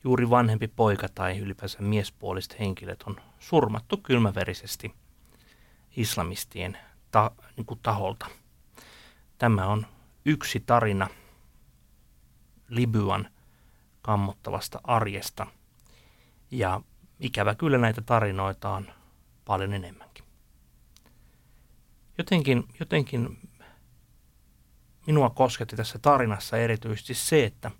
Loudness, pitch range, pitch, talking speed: -27 LUFS, 95-120 Hz, 110 Hz, 80 wpm